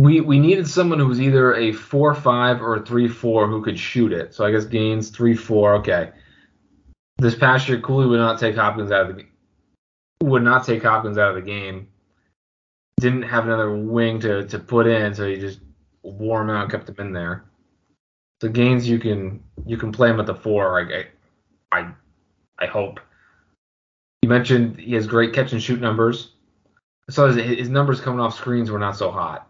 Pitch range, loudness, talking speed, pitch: 105-125 Hz, -19 LUFS, 200 wpm, 115 Hz